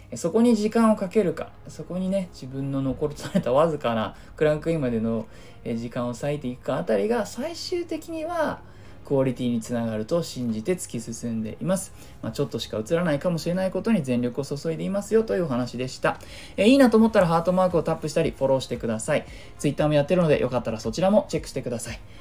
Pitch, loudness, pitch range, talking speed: 145 Hz, -25 LUFS, 120-185 Hz, 480 characters per minute